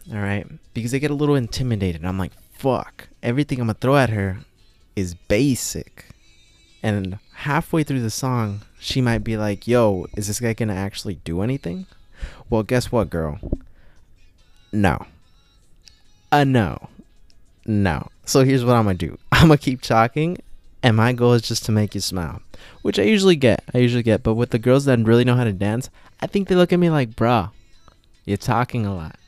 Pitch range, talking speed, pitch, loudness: 95-125 Hz, 195 wpm, 110 Hz, -20 LUFS